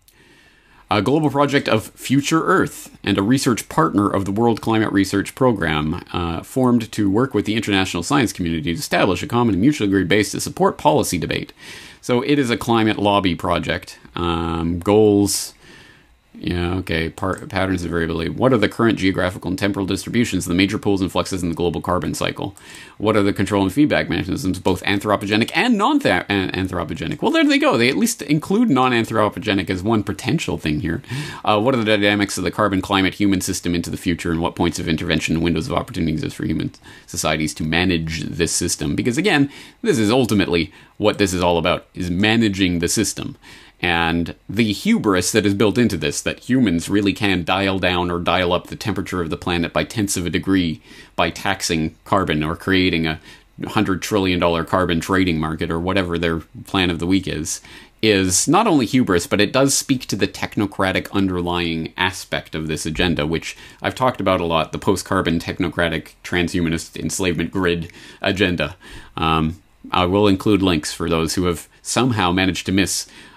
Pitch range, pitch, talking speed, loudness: 85-105 Hz, 95 Hz, 190 wpm, -19 LUFS